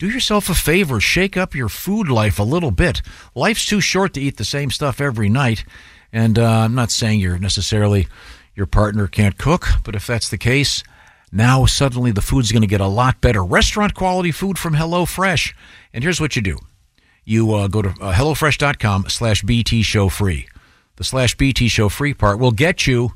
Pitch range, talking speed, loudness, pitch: 105-145 Hz, 200 wpm, -17 LUFS, 120 Hz